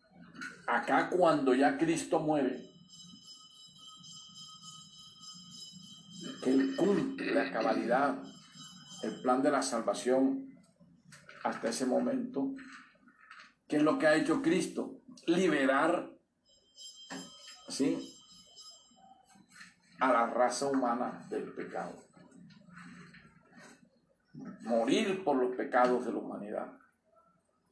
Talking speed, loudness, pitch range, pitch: 85 wpm, -31 LUFS, 150-250 Hz, 180 Hz